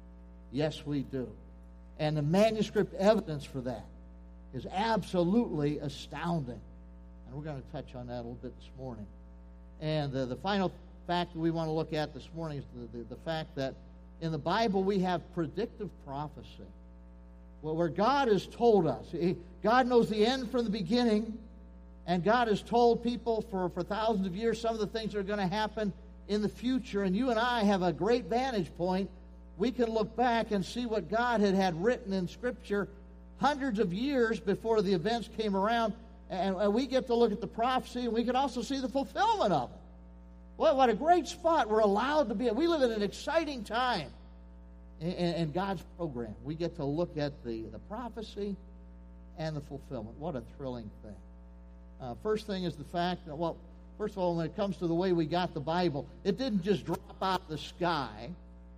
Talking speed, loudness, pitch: 205 wpm, -32 LUFS, 180 Hz